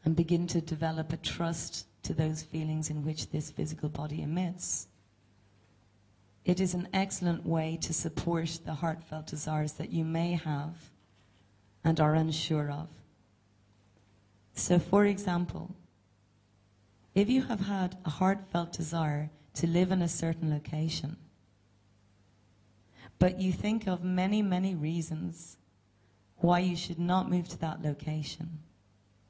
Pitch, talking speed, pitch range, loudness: 155 Hz, 130 wpm, 105-170 Hz, -32 LUFS